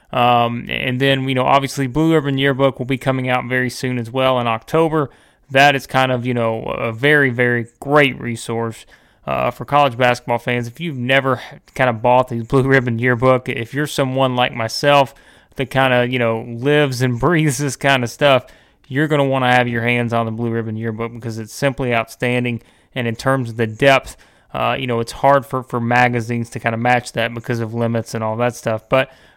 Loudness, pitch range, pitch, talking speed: -17 LUFS, 115-135 Hz, 125 Hz, 215 wpm